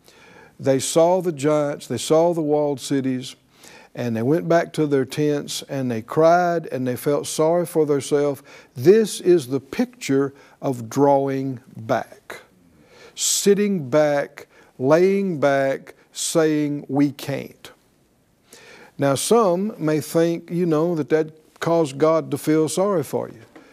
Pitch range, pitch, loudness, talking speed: 140-165 Hz, 150 Hz, -21 LUFS, 135 wpm